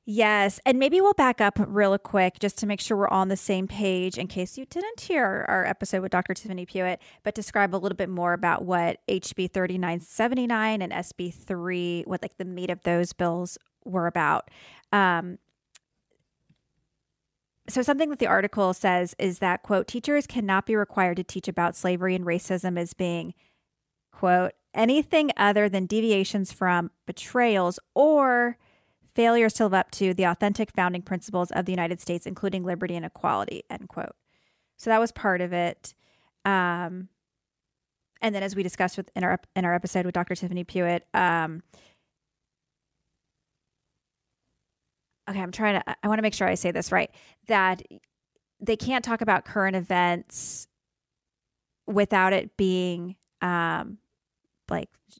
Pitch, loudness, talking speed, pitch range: 190 Hz, -26 LUFS, 160 wpm, 180-210 Hz